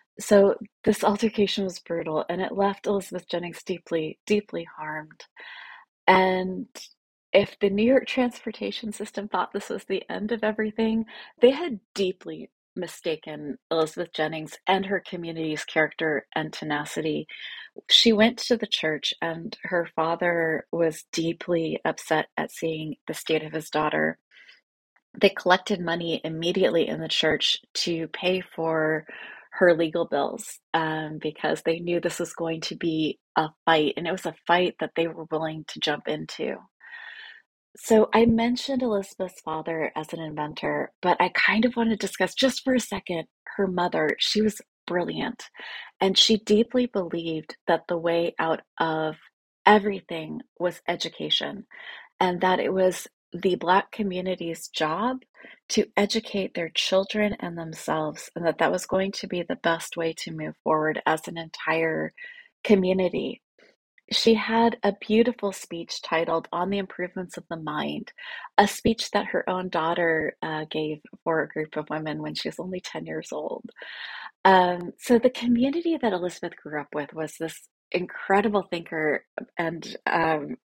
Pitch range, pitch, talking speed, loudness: 160-210 Hz, 180 Hz, 155 wpm, -25 LUFS